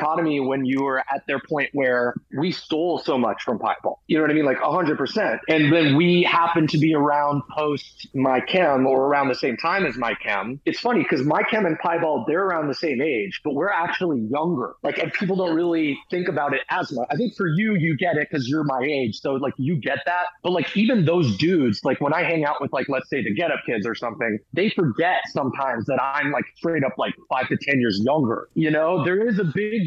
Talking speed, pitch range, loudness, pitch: 245 wpm, 135-175 Hz, -22 LUFS, 155 Hz